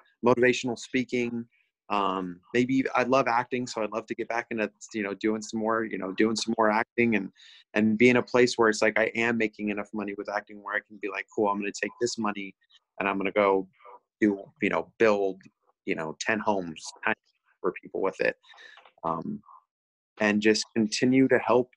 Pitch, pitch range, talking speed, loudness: 110 Hz, 100-120 Hz, 205 wpm, -27 LUFS